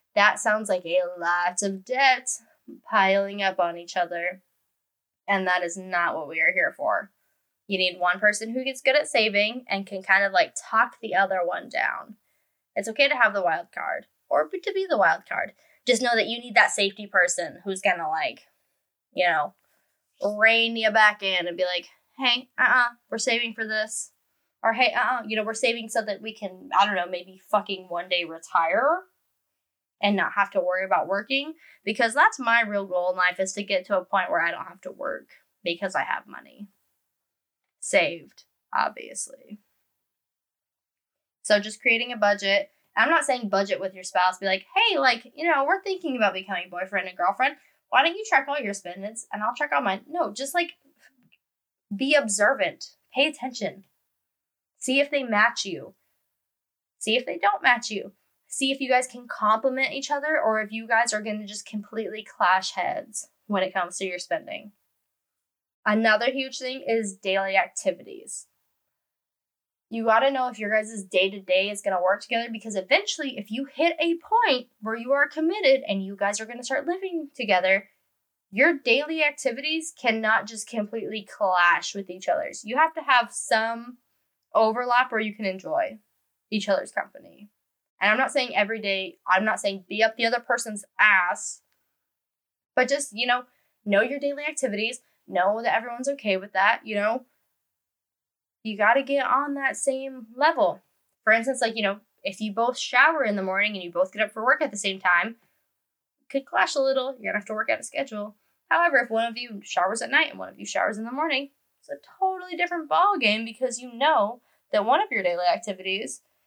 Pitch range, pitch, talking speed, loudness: 195-270 Hz, 225 Hz, 195 wpm, -24 LUFS